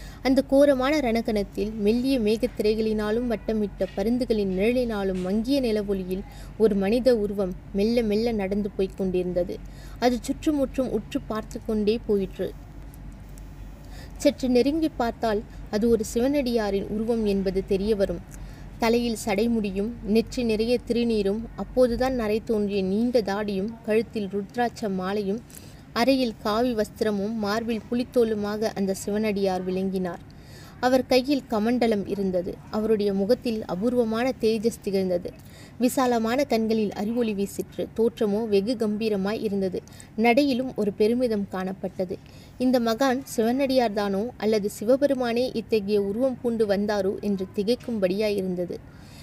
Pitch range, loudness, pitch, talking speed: 200-240 Hz, -25 LUFS, 220 Hz, 110 wpm